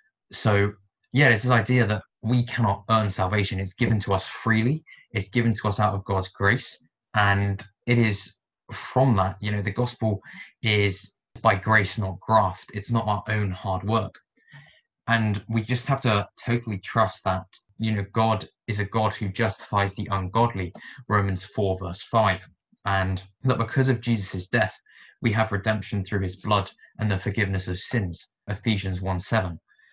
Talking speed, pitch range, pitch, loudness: 170 wpm, 95-115 Hz, 105 Hz, -25 LUFS